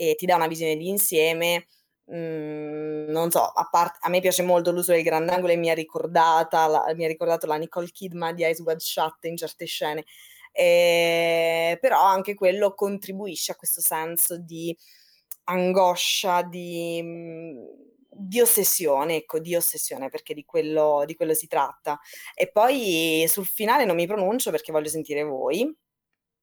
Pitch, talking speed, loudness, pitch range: 170 Hz, 155 wpm, -23 LUFS, 160-180 Hz